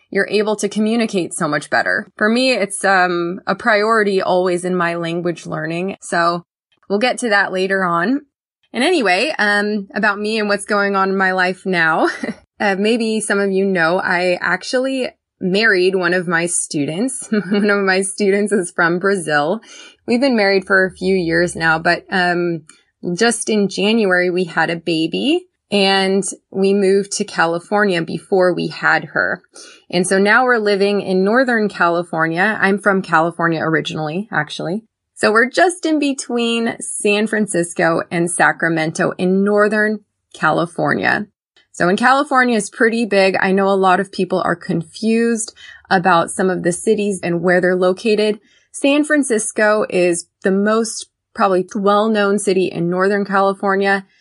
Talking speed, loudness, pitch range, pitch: 160 wpm, -16 LUFS, 180-215 Hz, 195 Hz